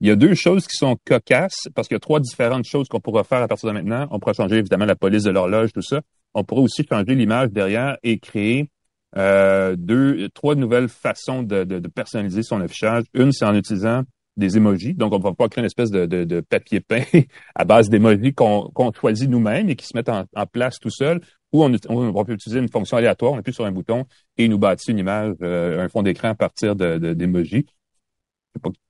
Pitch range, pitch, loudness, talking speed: 100-125 Hz, 110 Hz, -19 LUFS, 240 wpm